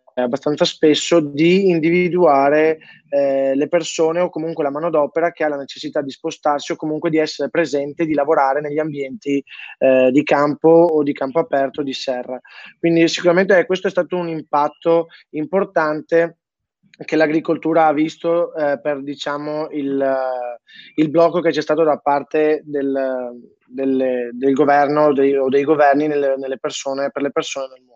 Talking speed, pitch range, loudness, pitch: 165 wpm, 140-165 Hz, -18 LUFS, 150 Hz